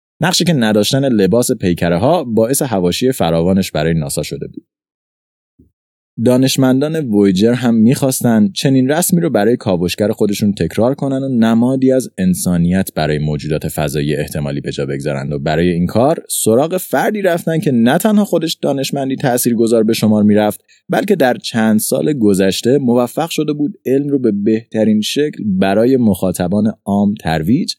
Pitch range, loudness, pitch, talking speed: 90-135 Hz, -14 LUFS, 110 Hz, 150 wpm